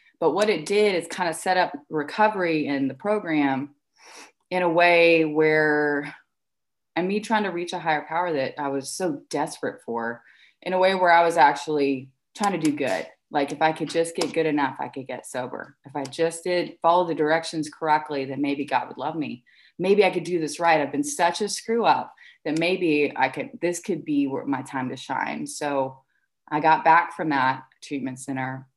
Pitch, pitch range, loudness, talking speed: 155 Hz, 140-175 Hz, -24 LUFS, 205 wpm